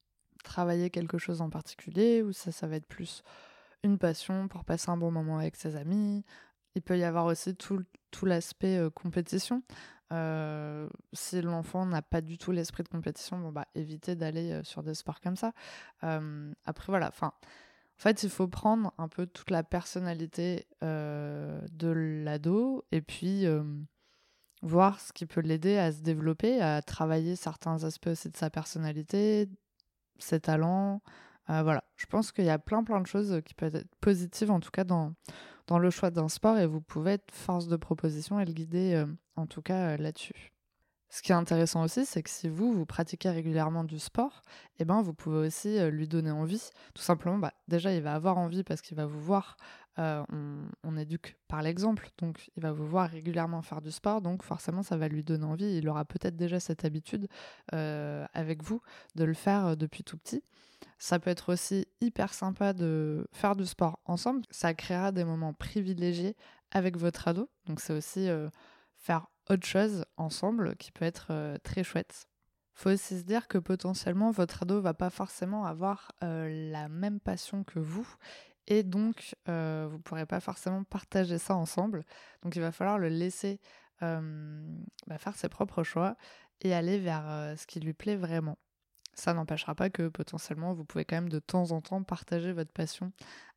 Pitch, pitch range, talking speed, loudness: 175 Hz, 160-195 Hz, 190 wpm, -33 LUFS